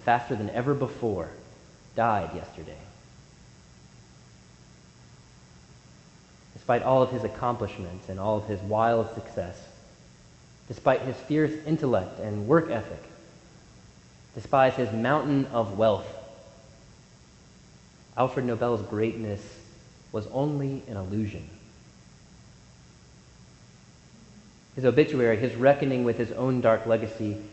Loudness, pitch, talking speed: -27 LUFS, 110 Hz, 100 wpm